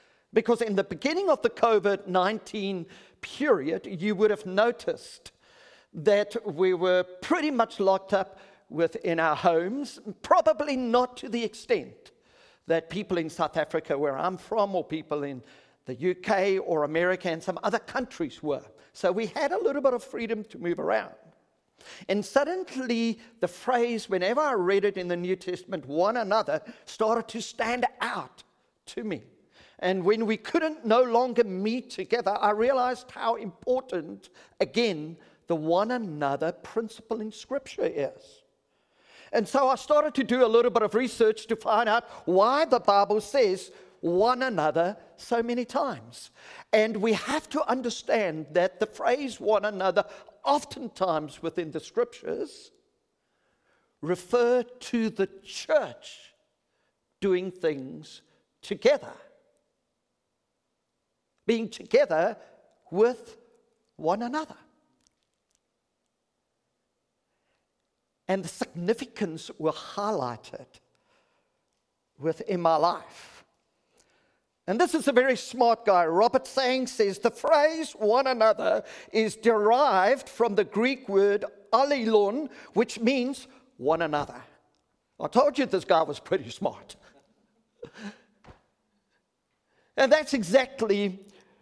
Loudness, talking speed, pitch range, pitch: -27 LUFS, 125 wpm, 185-255 Hz, 220 Hz